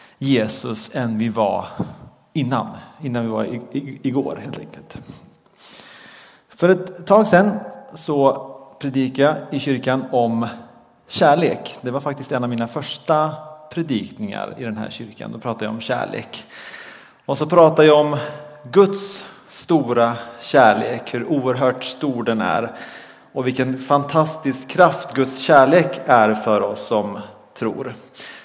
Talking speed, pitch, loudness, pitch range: 135 wpm, 135 Hz, -19 LUFS, 120-155 Hz